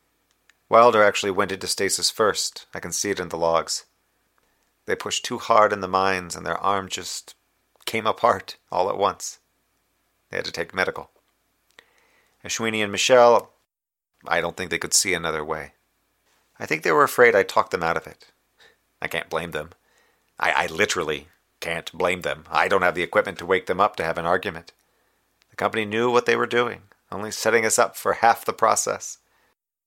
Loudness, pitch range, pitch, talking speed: -22 LUFS, 90-120 Hz, 105 Hz, 190 wpm